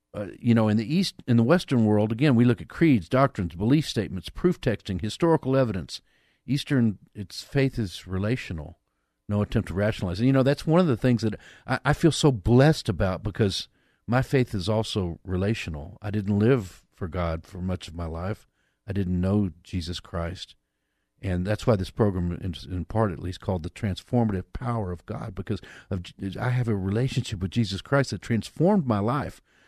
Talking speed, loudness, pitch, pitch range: 195 wpm, -26 LUFS, 105 Hz, 90-125 Hz